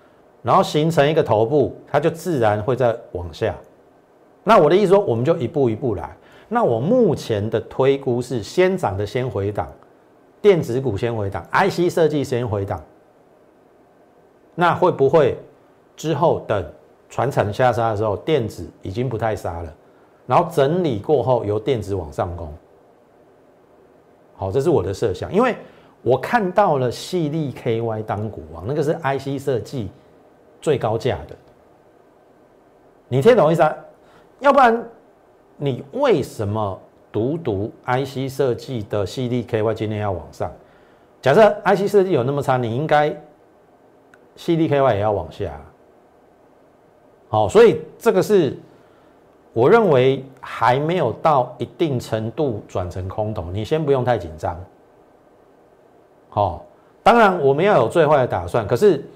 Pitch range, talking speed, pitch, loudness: 110-155 Hz, 220 characters per minute, 125 Hz, -19 LUFS